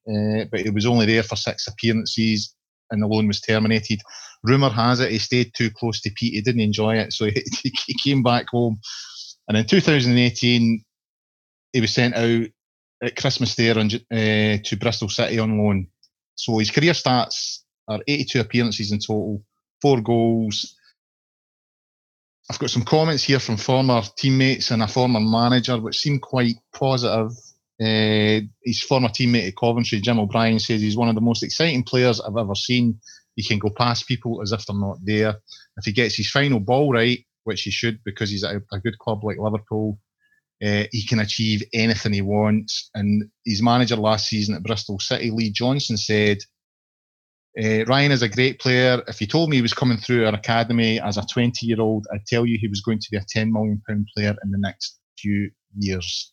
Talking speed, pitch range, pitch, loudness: 190 wpm, 105-120 Hz, 115 Hz, -21 LUFS